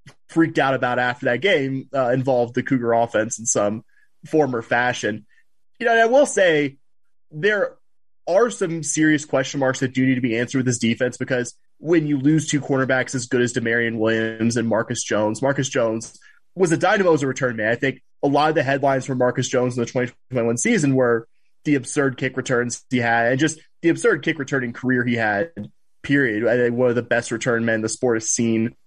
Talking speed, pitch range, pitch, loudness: 215 wpm, 120-145 Hz, 130 Hz, -20 LUFS